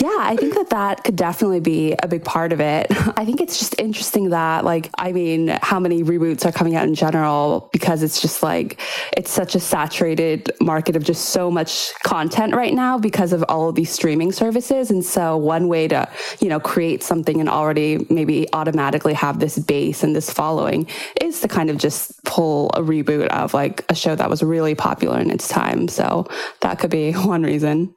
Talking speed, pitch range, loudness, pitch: 210 wpm, 155-185 Hz, -19 LUFS, 165 Hz